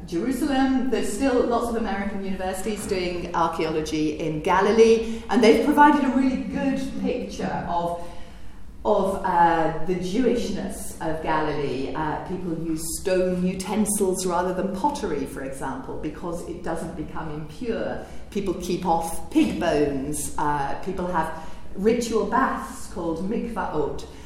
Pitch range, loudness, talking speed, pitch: 160-225 Hz, -24 LUFS, 130 wpm, 185 Hz